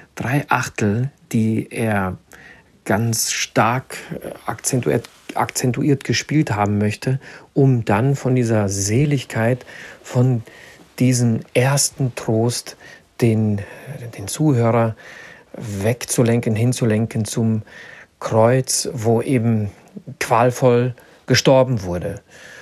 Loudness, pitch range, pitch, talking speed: -19 LUFS, 110-130 Hz, 120 Hz, 85 wpm